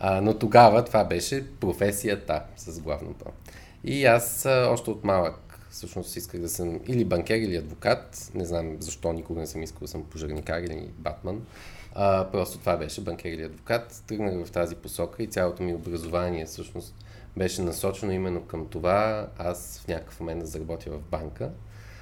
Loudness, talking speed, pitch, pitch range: -27 LUFS, 165 wpm, 90 Hz, 85-105 Hz